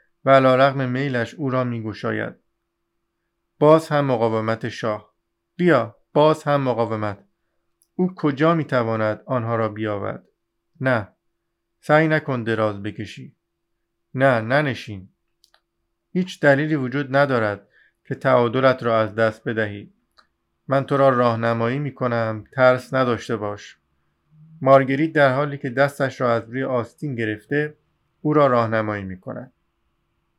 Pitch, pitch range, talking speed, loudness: 125 Hz, 110-140 Hz, 125 wpm, -20 LUFS